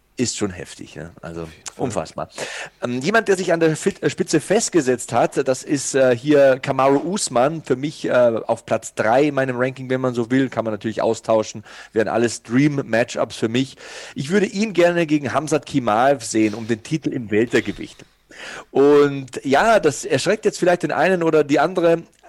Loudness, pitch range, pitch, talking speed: -19 LUFS, 120-160 Hz, 135 Hz, 180 wpm